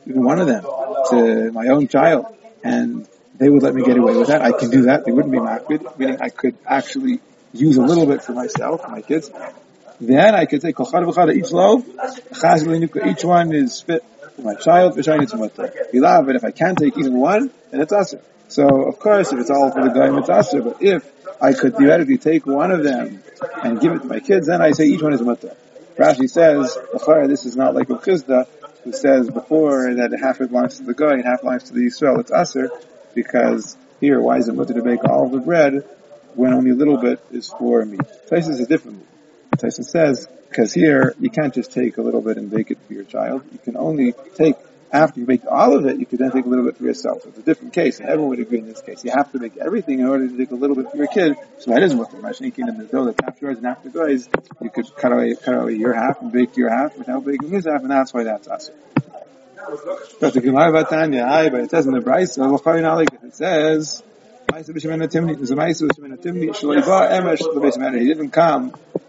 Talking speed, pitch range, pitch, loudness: 225 wpm, 130-165 Hz, 140 Hz, -17 LUFS